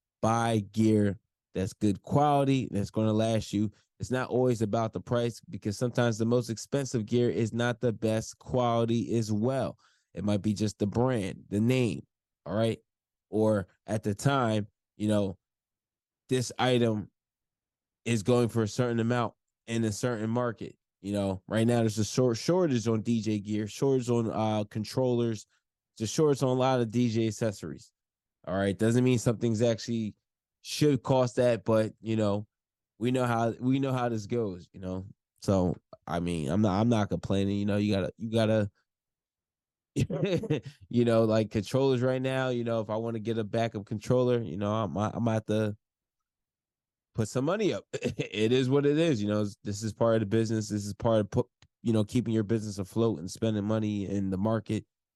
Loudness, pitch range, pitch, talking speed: -29 LUFS, 105-120 Hz, 110 Hz, 190 wpm